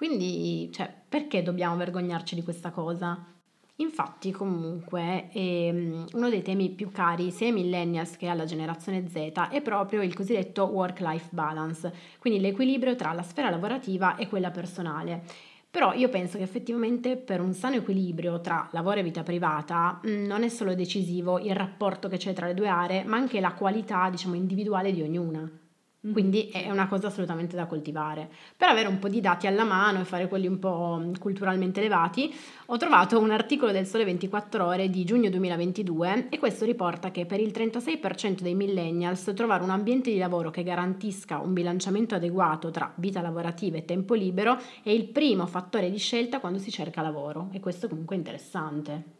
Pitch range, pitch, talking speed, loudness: 175-210 Hz, 185 Hz, 175 wpm, -28 LUFS